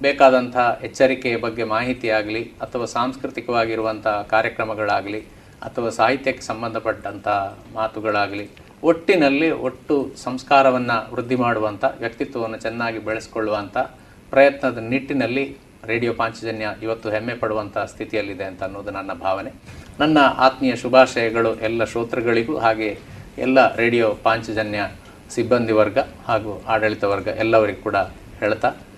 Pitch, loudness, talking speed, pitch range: 115 Hz, -21 LUFS, 100 wpm, 110-130 Hz